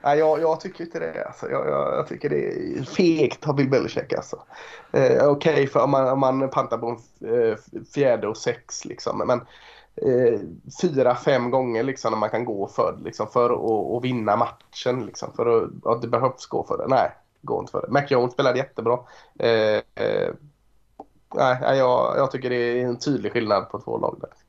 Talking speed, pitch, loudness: 185 wpm, 145 Hz, -23 LUFS